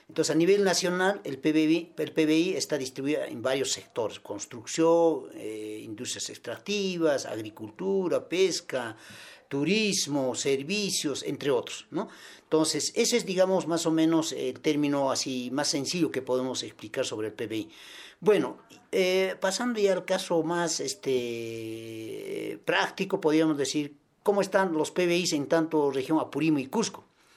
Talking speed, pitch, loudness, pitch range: 140 wpm, 165 Hz, -28 LUFS, 145-195 Hz